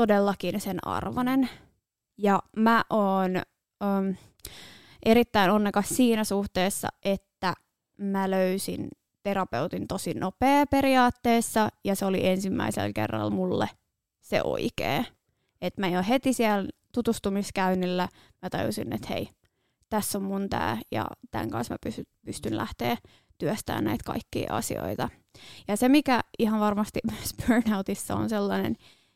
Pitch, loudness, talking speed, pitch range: 200 Hz, -27 LUFS, 125 wpm, 185-225 Hz